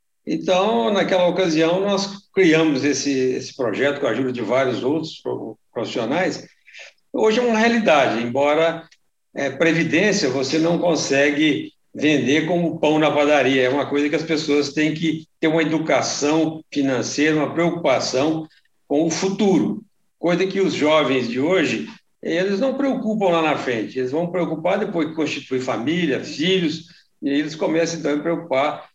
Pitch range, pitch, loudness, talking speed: 145-175 Hz, 160 Hz, -20 LUFS, 150 wpm